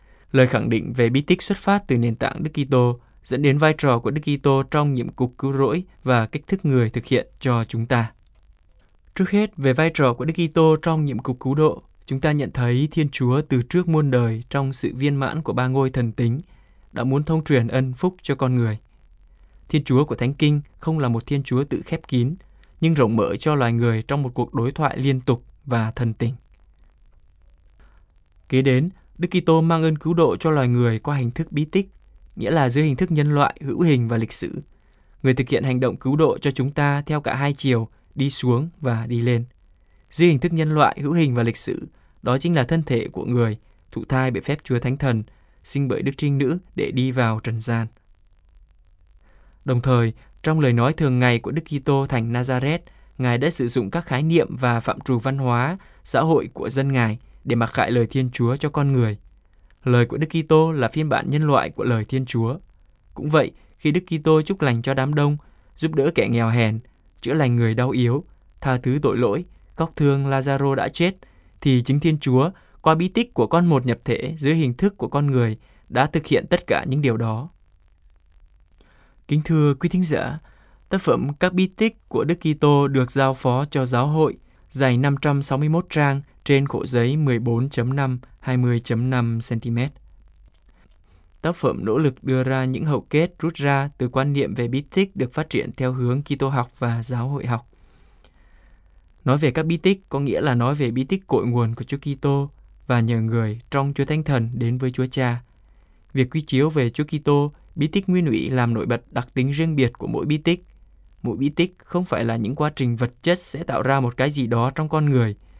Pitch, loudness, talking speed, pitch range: 130 Hz, -21 LUFS, 215 wpm, 120-150 Hz